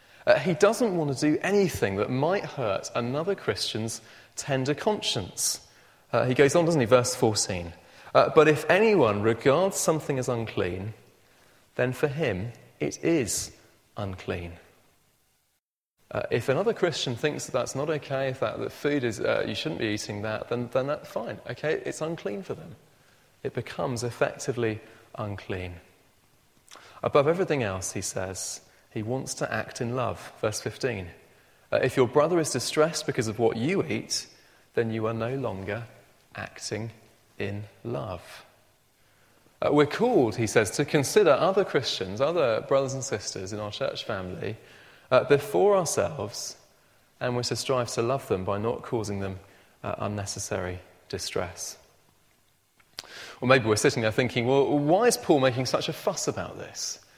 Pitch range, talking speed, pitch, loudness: 105-150 Hz, 160 wpm, 120 Hz, -27 LUFS